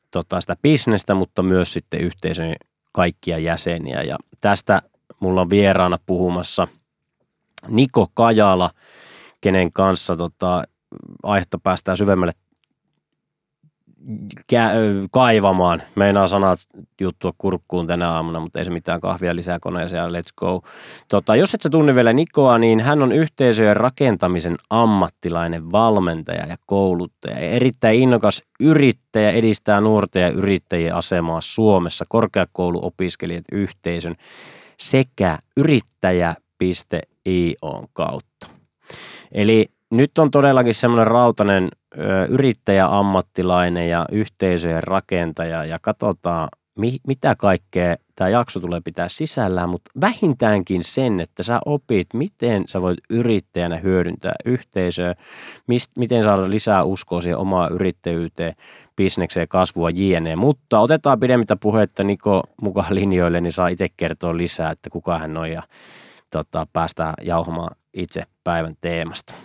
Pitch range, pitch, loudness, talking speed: 85-115 Hz, 95 Hz, -19 LUFS, 115 wpm